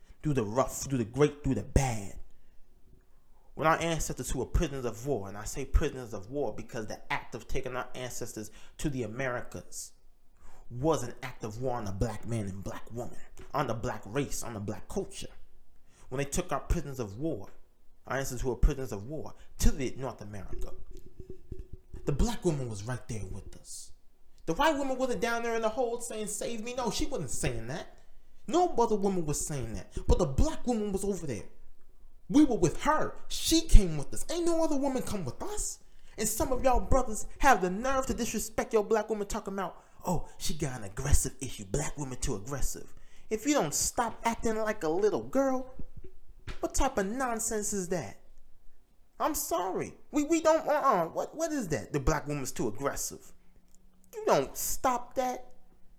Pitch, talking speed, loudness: 150 Hz, 200 wpm, -32 LUFS